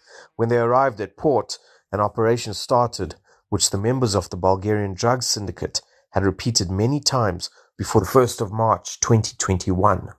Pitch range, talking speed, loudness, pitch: 95-120 Hz, 155 wpm, -21 LUFS, 105 Hz